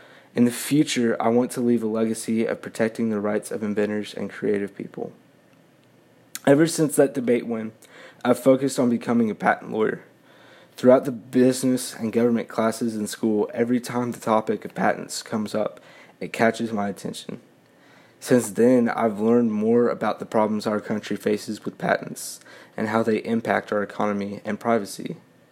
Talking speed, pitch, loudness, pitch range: 165 wpm, 115 Hz, -23 LUFS, 105-125 Hz